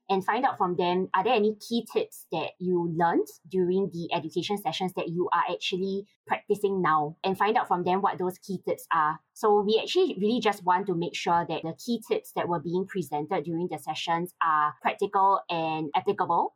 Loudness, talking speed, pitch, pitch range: -27 LUFS, 205 wpm, 185 Hz, 170-200 Hz